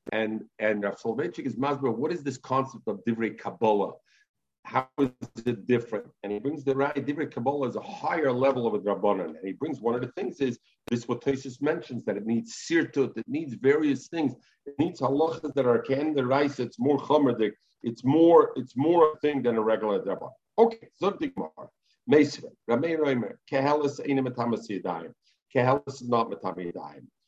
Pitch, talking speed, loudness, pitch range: 135 Hz, 180 wpm, -27 LUFS, 115-145 Hz